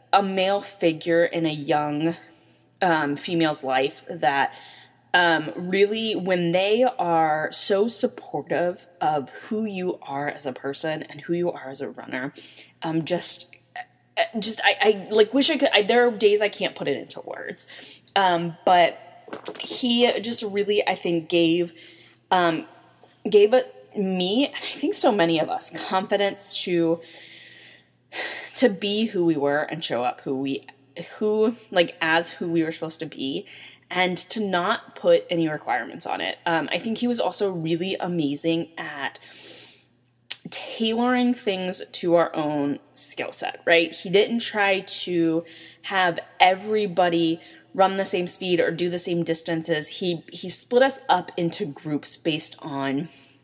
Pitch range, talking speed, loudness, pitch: 165-205 Hz, 155 wpm, -23 LUFS, 175 Hz